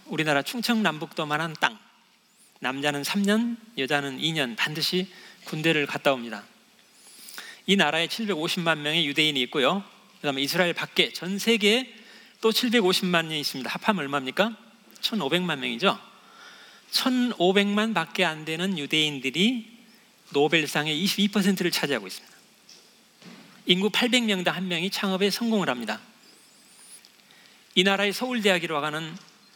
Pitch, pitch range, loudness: 185 Hz, 155-215 Hz, -24 LUFS